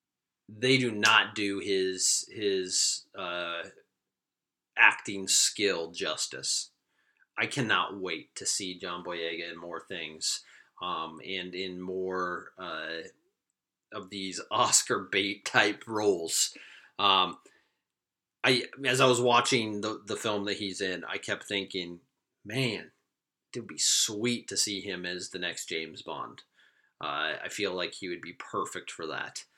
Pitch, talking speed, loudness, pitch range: 95 Hz, 140 wpm, -29 LUFS, 90-105 Hz